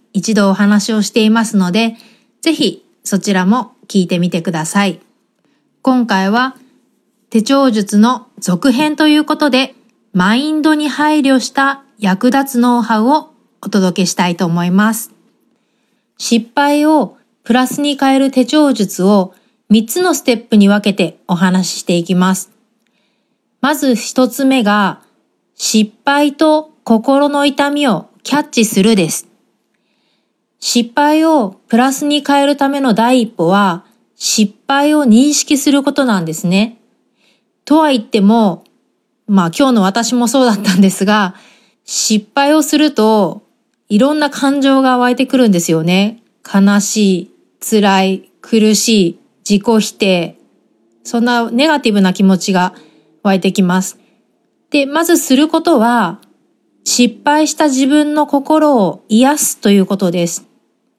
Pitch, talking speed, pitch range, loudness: 230 Hz, 255 characters per minute, 200-275 Hz, -12 LUFS